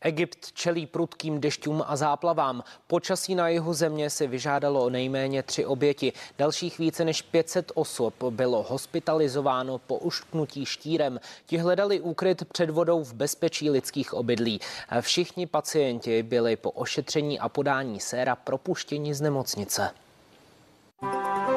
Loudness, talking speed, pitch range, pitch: -27 LUFS, 125 wpm, 130-170 Hz, 150 Hz